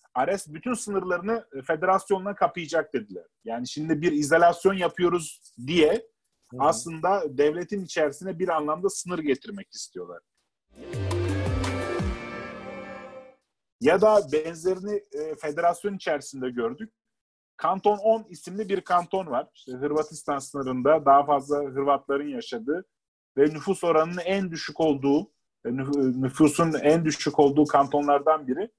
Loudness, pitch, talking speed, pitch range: -25 LUFS, 165 Hz, 105 wpm, 145-195 Hz